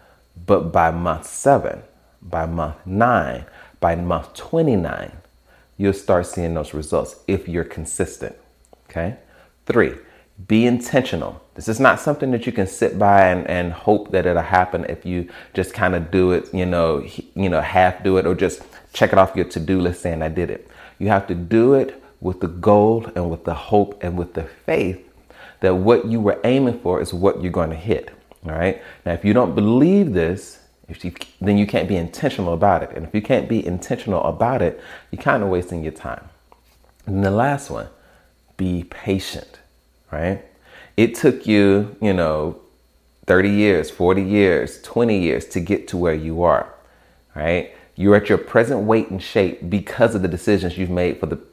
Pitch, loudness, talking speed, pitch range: 90 Hz, -19 LUFS, 190 wpm, 85-100 Hz